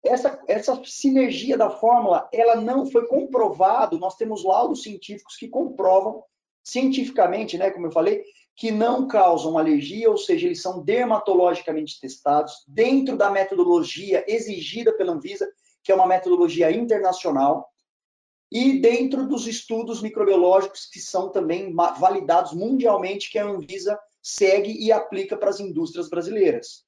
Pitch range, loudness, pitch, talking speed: 185-260 Hz, -21 LUFS, 215 Hz, 135 wpm